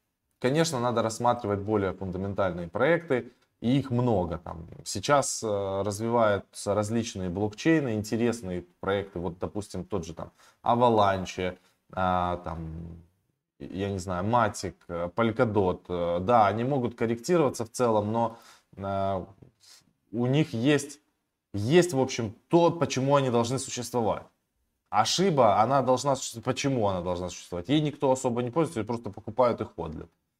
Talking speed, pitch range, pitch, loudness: 125 wpm, 95-125 Hz, 110 Hz, -27 LUFS